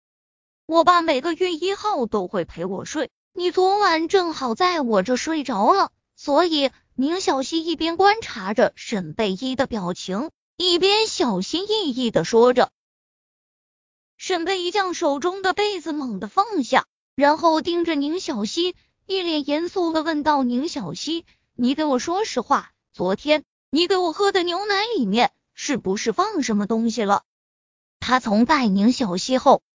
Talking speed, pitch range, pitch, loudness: 225 characters per minute, 245-355 Hz, 310 Hz, -21 LUFS